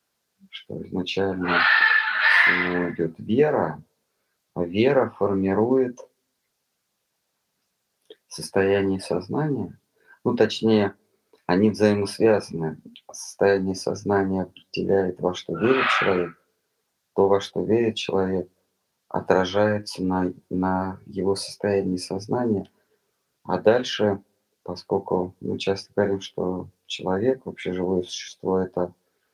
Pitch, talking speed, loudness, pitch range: 95 Hz, 90 wpm, -23 LUFS, 90-100 Hz